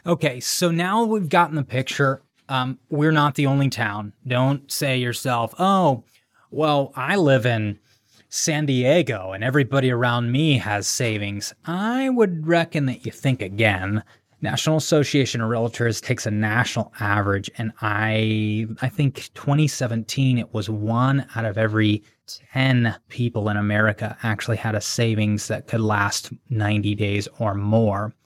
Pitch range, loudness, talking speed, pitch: 110-140 Hz, -22 LUFS, 150 wpm, 120 Hz